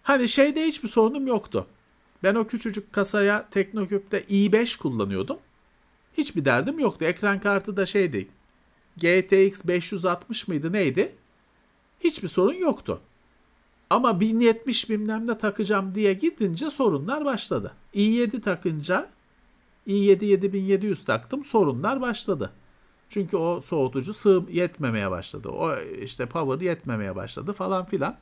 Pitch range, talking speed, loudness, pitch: 180-230 Hz, 115 wpm, -24 LUFS, 200 Hz